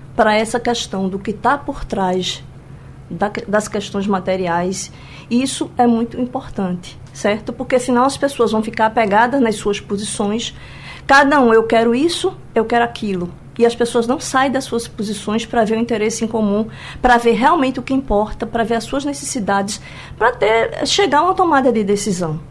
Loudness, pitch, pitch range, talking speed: -17 LUFS, 225 Hz, 205-250 Hz, 180 wpm